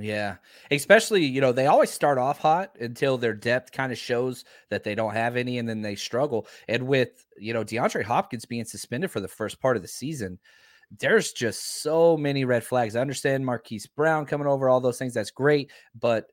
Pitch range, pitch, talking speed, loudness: 115-135 Hz, 125 Hz, 210 wpm, -25 LUFS